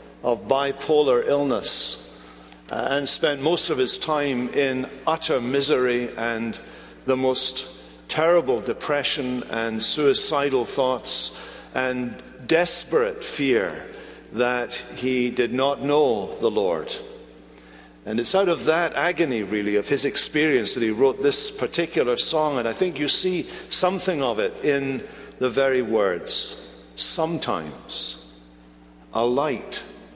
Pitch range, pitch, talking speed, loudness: 120-165 Hz, 140 Hz, 120 wpm, -23 LUFS